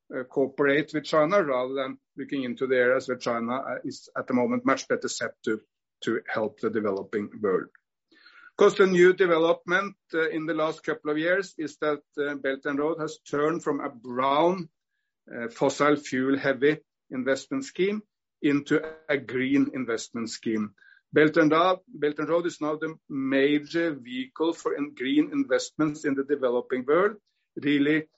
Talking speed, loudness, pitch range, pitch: 170 wpm, -26 LUFS, 135-170 Hz, 150 Hz